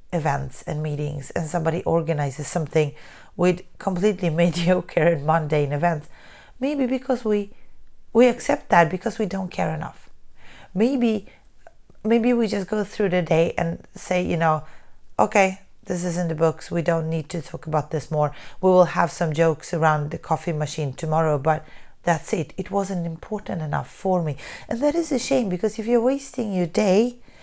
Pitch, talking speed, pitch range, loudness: 175 Hz, 175 wpm, 160-210 Hz, -23 LUFS